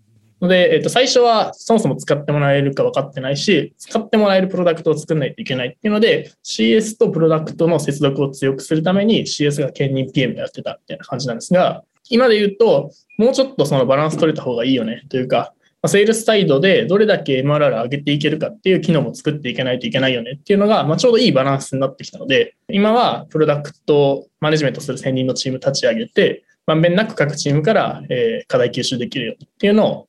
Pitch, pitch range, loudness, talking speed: 160 Hz, 140-215 Hz, -17 LUFS, 495 characters per minute